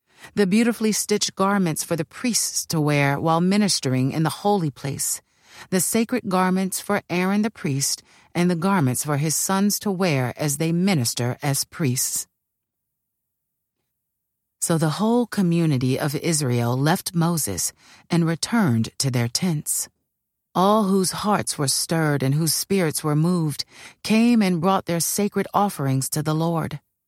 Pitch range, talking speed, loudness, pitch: 145-195 Hz, 150 wpm, -22 LUFS, 165 Hz